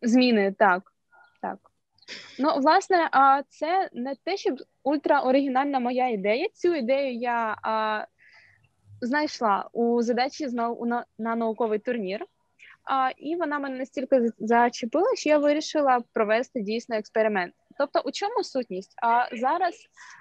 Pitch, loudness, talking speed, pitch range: 255 Hz, -25 LUFS, 115 wpm, 230-295 Hz